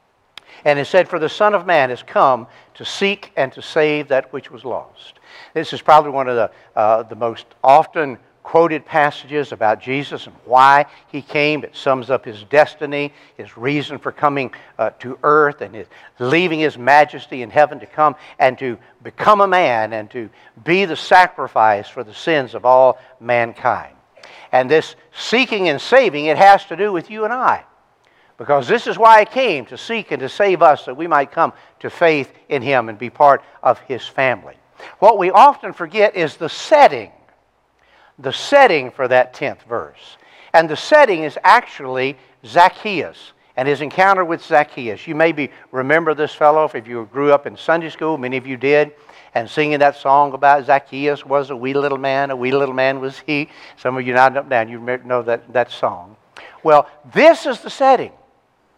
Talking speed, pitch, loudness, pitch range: 190 wpm, 145 Hz, -16 LUFS, 130-160 Hz